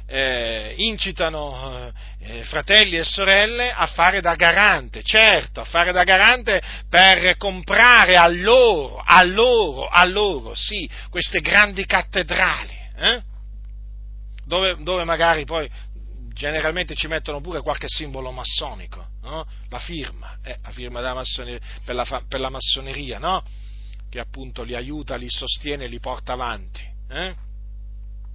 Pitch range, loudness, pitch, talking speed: 115-180 Hz, -16 LUFS, 145 Hz, 130 wpm